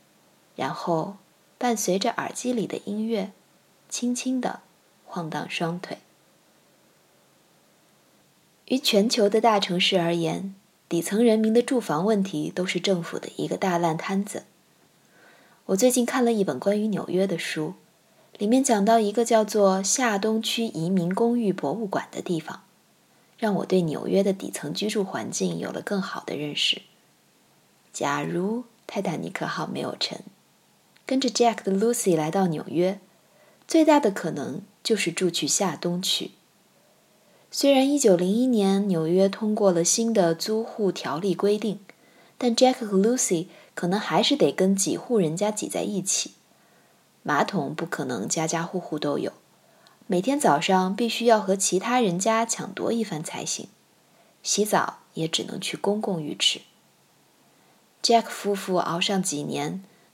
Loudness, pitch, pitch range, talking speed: -24 LUFS, 200 Hz, 180-225 Hz, 225 characters per minute